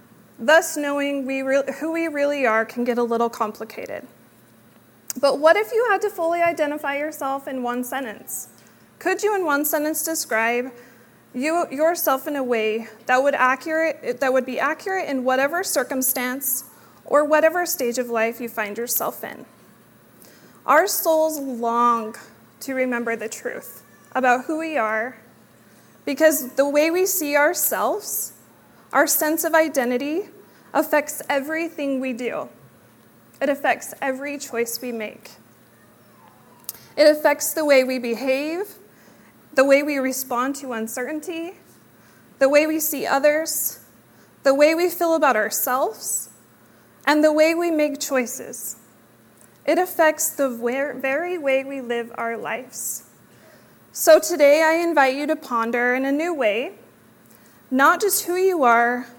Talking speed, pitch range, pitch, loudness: 140 wpm, 245-315 Hz, 275 Hz, -21 LUFS